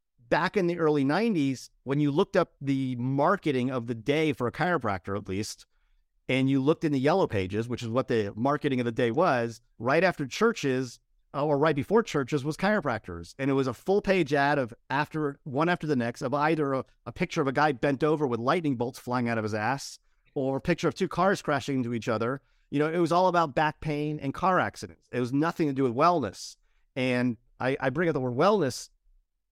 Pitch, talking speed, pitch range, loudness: 140 Hz, 225 wpm, 125-160 Hz, -27 LUFS